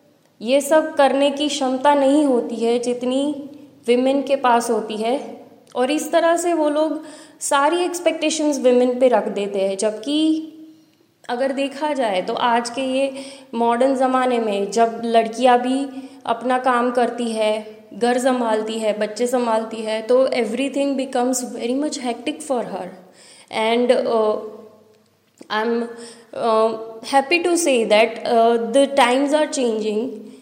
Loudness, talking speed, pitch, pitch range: -19 LUFS, 140 wpm, 250 Hz, 230-280 Hz